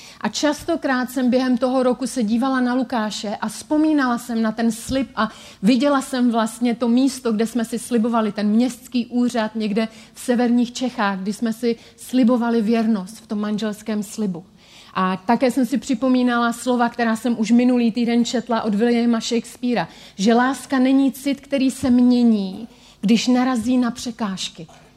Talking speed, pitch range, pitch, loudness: 165 wpm, 225-255 Hz, 235 Hz, -20 LUFS